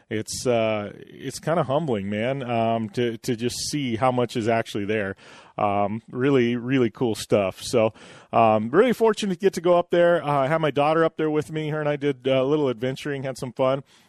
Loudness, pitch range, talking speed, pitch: -23 LUFS, 115-155 Hz, 220 wpm, 130 Hz